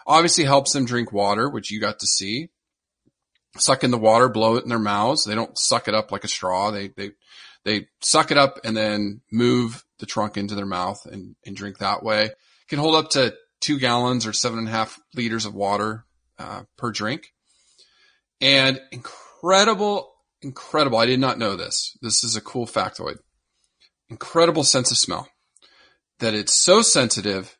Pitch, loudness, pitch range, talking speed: 115 Hz, -20 LUFS, 105-135 Hz, 185 wpm